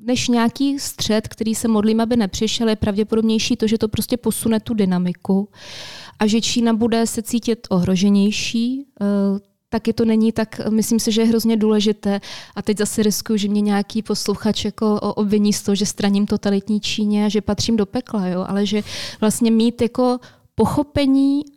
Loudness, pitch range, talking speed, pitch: -19 LUFS, 205-230 Hz, 175 wpm, 220 Hz